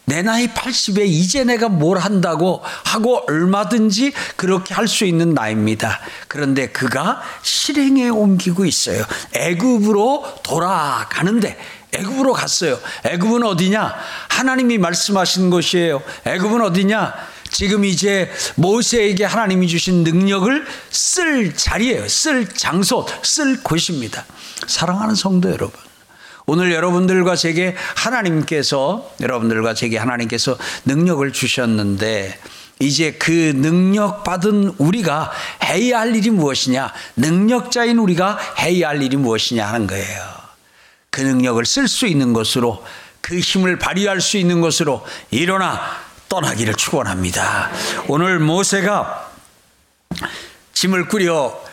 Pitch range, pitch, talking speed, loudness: 145-215 Hz, 185 Hz, 280 characters per minute, -17 LUFS